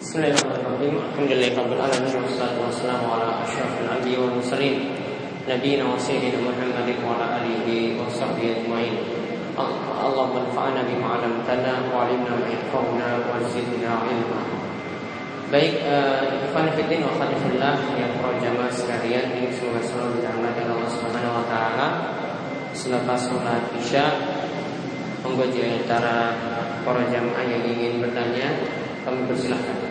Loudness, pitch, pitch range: -24 LUFS, 125 Hz, 120-130 Hz